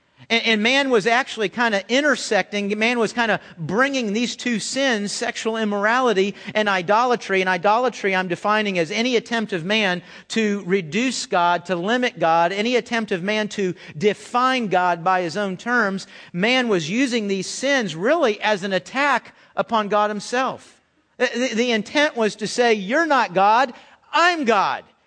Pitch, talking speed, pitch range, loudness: 215 Hz, 165 wpm, 195-240 Hz, -20 LUFS